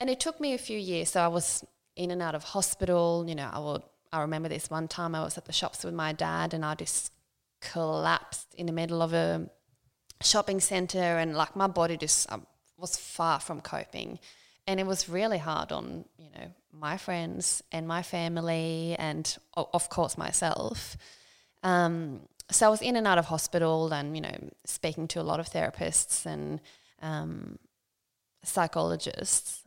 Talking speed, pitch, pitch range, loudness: 185 wpm, 165 Hz, 155-180 Hz, -30 LUFS